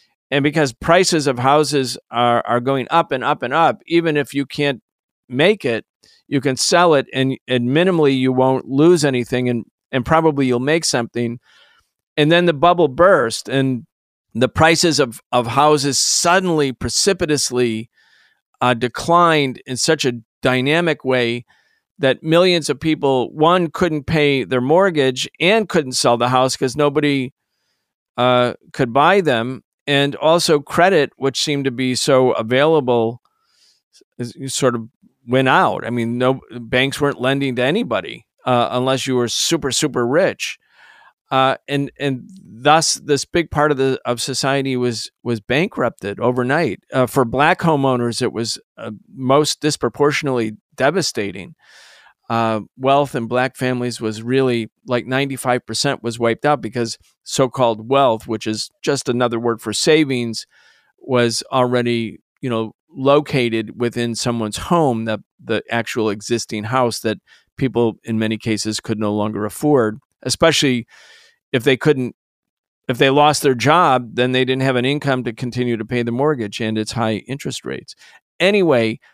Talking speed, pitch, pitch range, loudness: 150 wpm, 130 Hz, 120-145 Hz, -17 LUFS